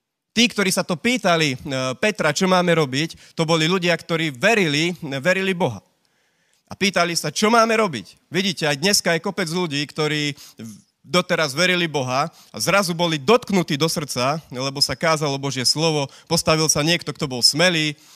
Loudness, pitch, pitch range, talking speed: -19 LUFS, 165 Hz, 150-180 Hz, 160 wpm